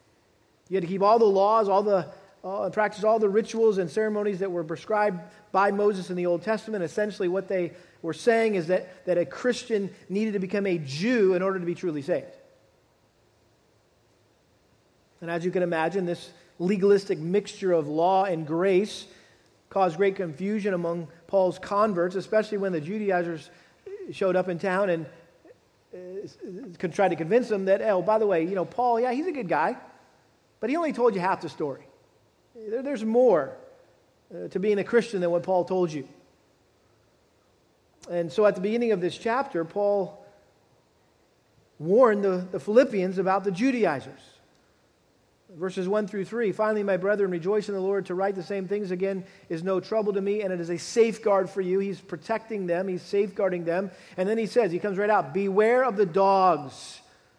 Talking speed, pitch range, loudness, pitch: 185 wpm, 180-210 Hz, -26 LUFS, 195 Hz